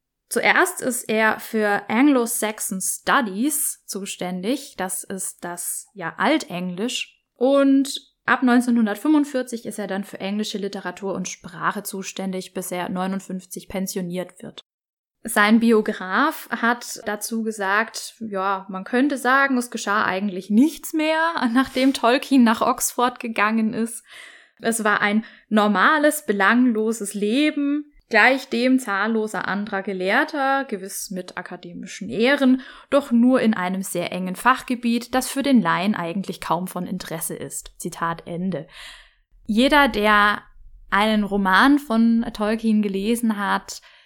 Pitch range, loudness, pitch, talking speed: 195-255 Hz, -21 LUFS, 220 Hz, 125 wpm